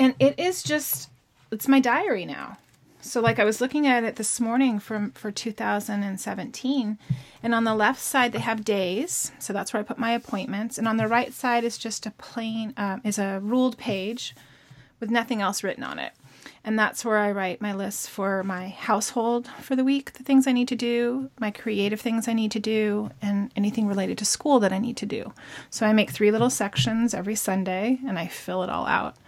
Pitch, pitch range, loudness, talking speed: 220 Hz, 205-240 Hz, -25 LUFS, 215 wpm